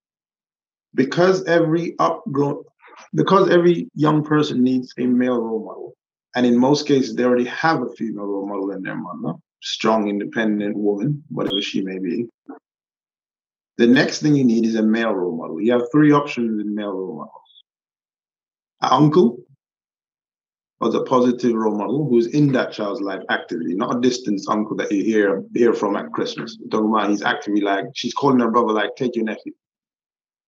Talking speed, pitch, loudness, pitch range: 170 wpm, 120 Hz, -19 LUFS, 105-145 Hz